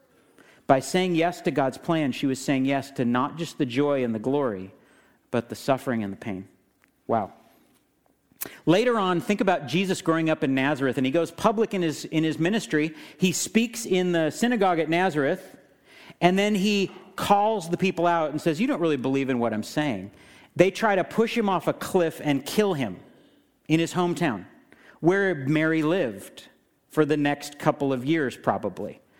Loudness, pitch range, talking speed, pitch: -25 LUFS, 140-185 Hz, 185 wpm, 160 Hz